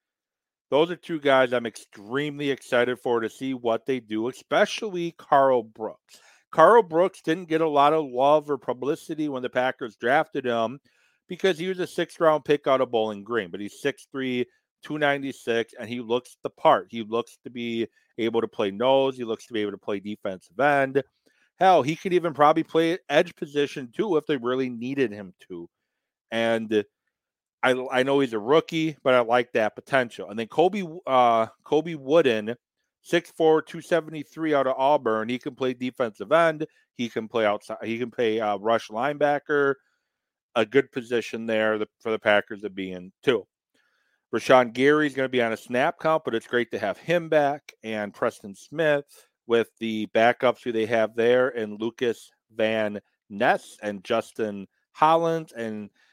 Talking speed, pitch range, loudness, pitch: 175 wpm, 115-150 Hz, -24 LUFS, 130 Hz